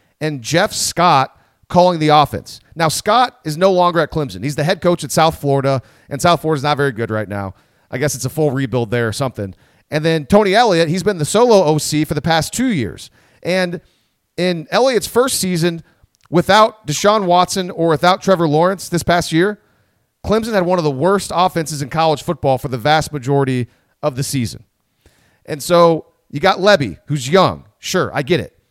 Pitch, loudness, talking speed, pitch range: 155 Hz, -16 LUFS, 195 wpm, 140-180 Hz